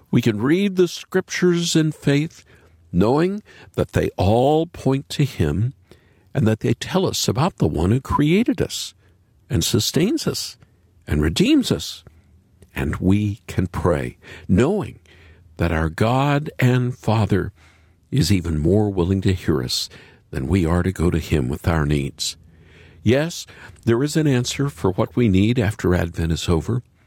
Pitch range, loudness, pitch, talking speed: 85-130 Hz, -20 LUFS, 100 Hz, 155 wpm